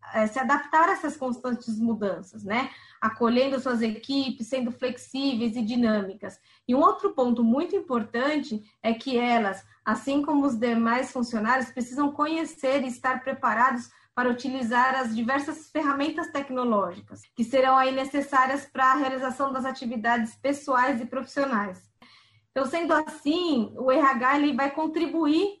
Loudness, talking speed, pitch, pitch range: -26 LUFS, 140 wpm, 260 Hz, 235-280 Hz